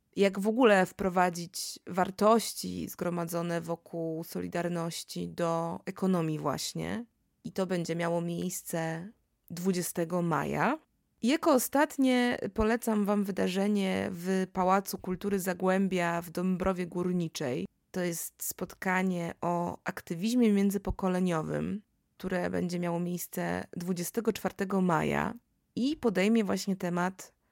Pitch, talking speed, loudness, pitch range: 185 Hz, 100 wpm, -31 LUFS, 170-200 Hz